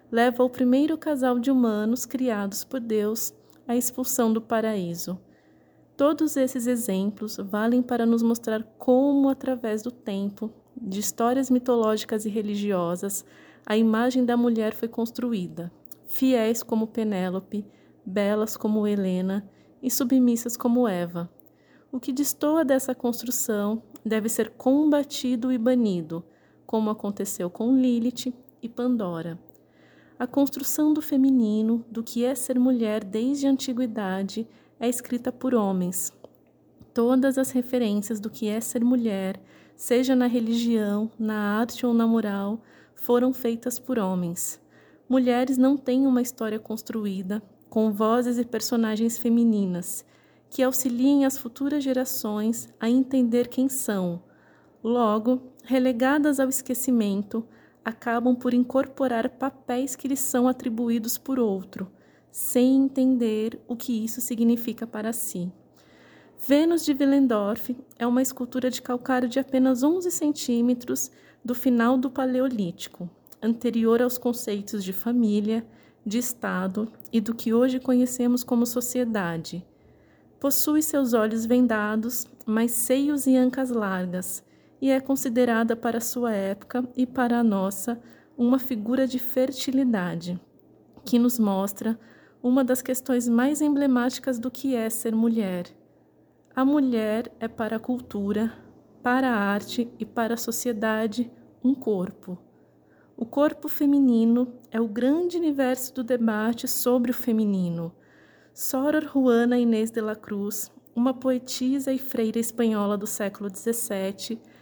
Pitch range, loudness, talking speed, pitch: 220-255 Hz, -25 LUFS, 130 wpm, 240 Hz